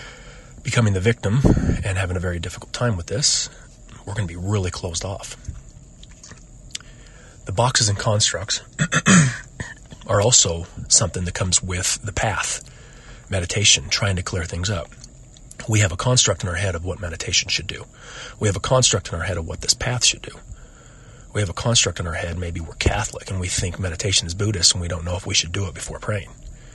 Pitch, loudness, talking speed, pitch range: 105 Hz, -20 LUFS, 195 wpm, 95-125 Hz